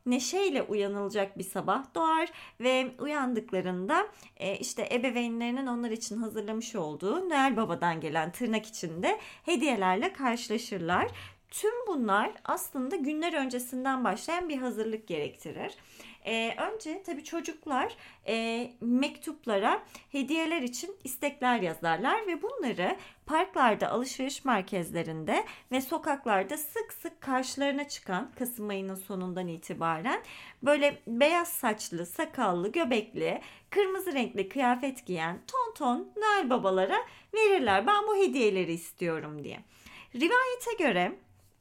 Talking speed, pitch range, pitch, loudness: 110 wpm, 200-320 Hz, 250 Hz, -31 LUFS